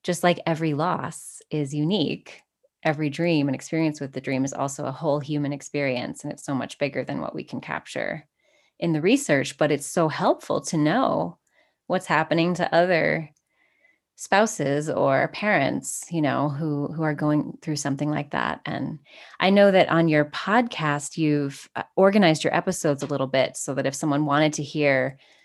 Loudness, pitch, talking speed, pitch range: -24 LUFS, 150 Hz, 180 wpm, 145-165 Hz